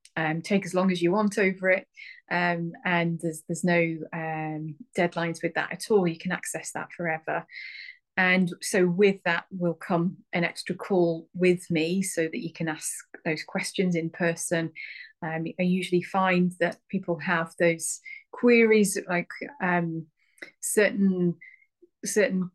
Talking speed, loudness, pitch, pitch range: 155 wpm, -26 LUFS, 175 Hz, 170-190 Hz